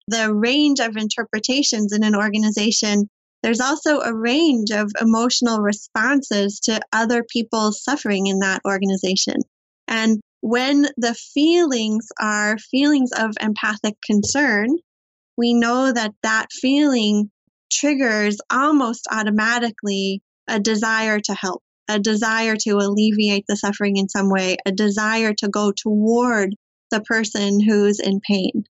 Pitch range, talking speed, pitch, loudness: 210-235 Hz, 125 wpm, 220 Hz, -19 LUFS